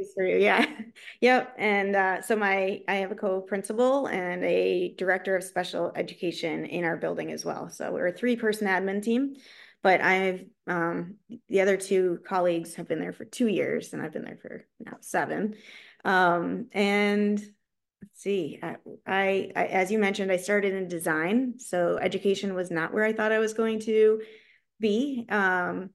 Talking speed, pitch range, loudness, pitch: 180 wpm, 180-215 Hz, -27 LUFS, 195 Hz